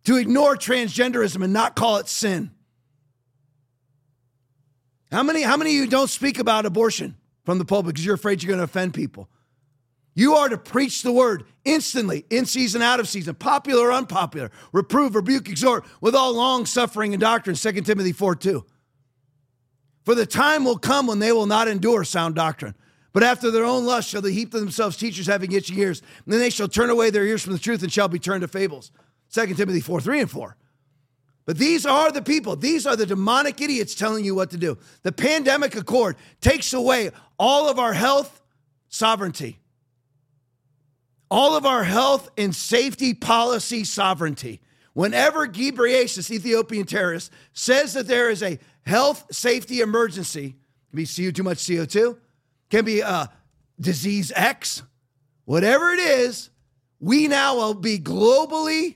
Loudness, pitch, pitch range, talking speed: -21 LUFS, 205 Hz, 150-245 Hz, 175 wpm